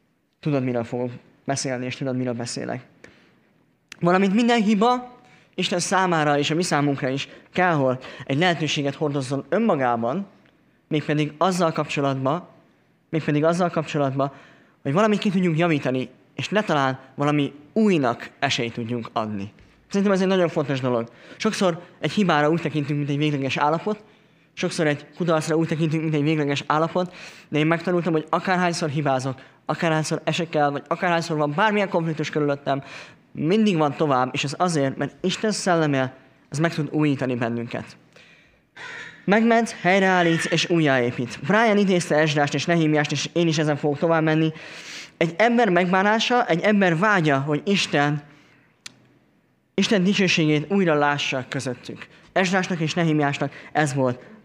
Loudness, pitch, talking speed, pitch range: -22 LUFS, 155 Hz, 140 wpm, 140-180 Hz